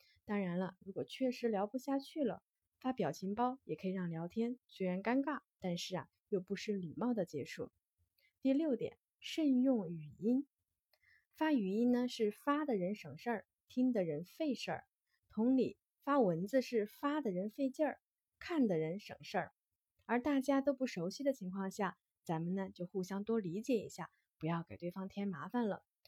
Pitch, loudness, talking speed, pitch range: 210 Hz, -39 LUFS, 255 characters per minute, 185-260 Hz